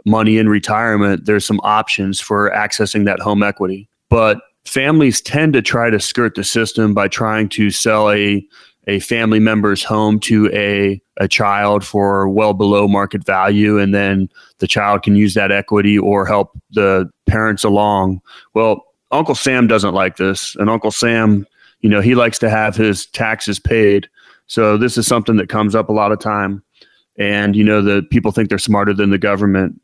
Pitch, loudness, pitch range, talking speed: 105 Hz, -14 LUFS, 100-110 Hz, 185 wpm